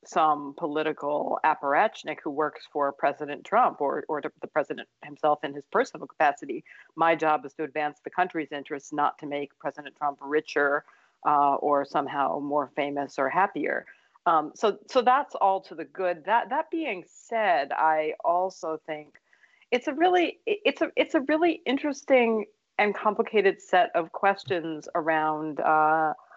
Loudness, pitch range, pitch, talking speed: -26 LUFS, 150-205 Hz, 160 Hz, 155 wpm